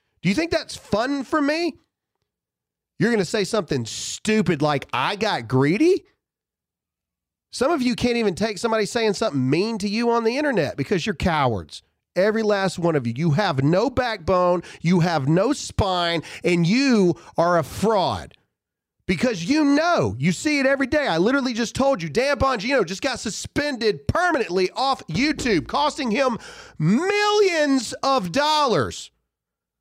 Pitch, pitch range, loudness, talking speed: 225 Hz, 175-275 Hz, -21 LUFS, 160 wpm